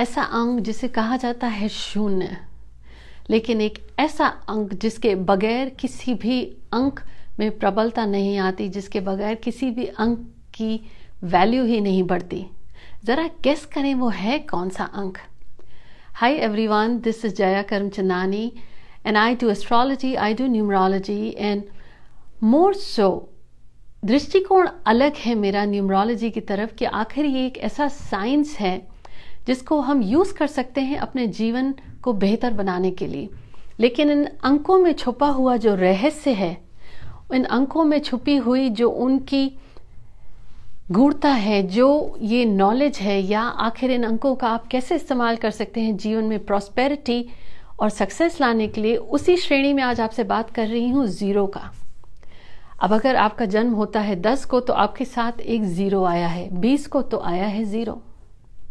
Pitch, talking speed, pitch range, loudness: 225 Hz, 160 wpm, 205-260 Hz, -21 LUFS